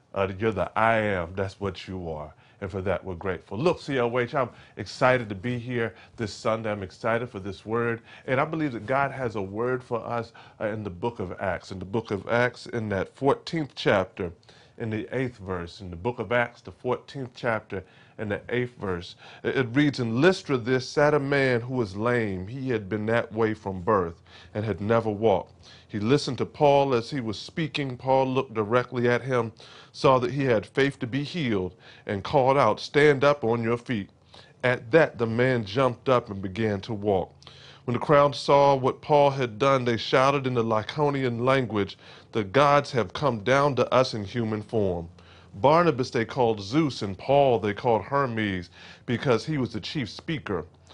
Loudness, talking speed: -26 LUFS, 200 wpm